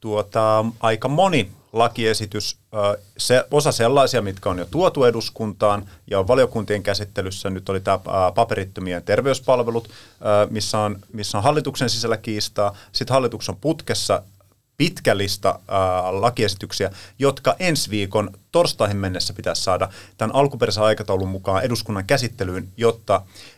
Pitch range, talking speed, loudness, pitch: 100-120 Hz, 120 wpm, -21 LUFS, 105 Hz